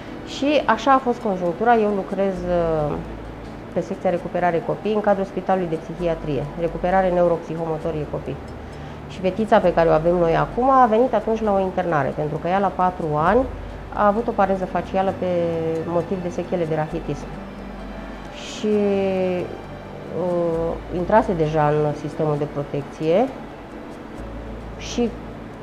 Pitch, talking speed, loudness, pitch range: 175 Hz, 140 wpm, -21 LUFS, 160-195 Hz